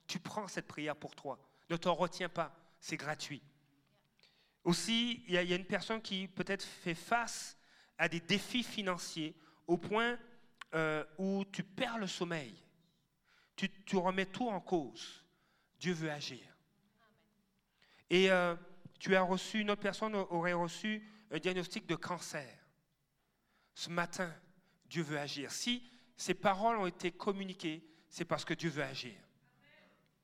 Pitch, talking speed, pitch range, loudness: 180 Hz, 150 wpm, 160-200 Hz, -37 LUFS